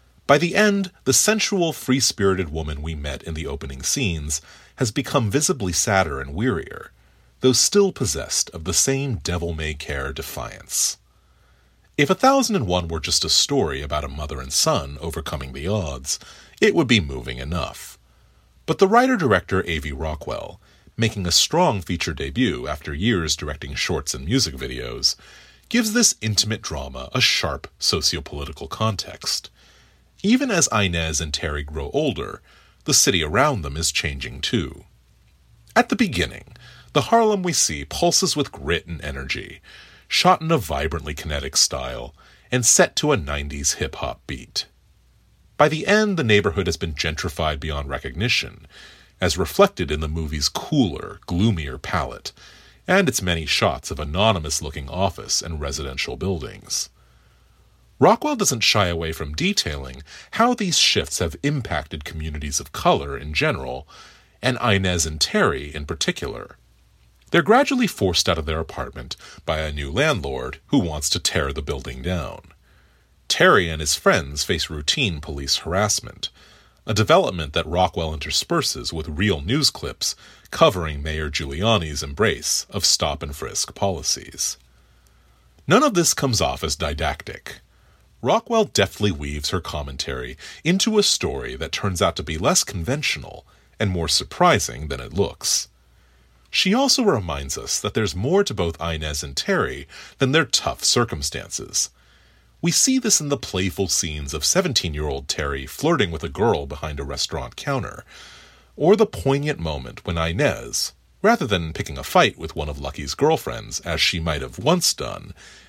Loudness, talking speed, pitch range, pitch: -21 LUFS, 155 wpm, 75-115 Hz, 85 Hz